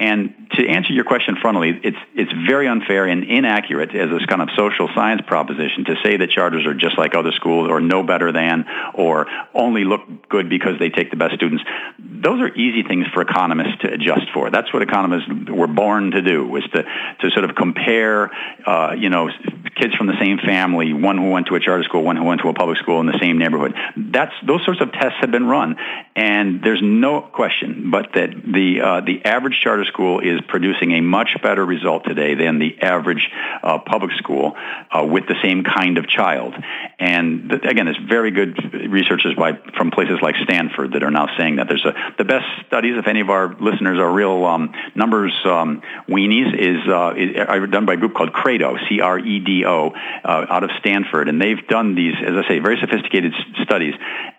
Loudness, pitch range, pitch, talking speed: -17 LUFS, 85-105 Hz, 95 Hz, 210 wpm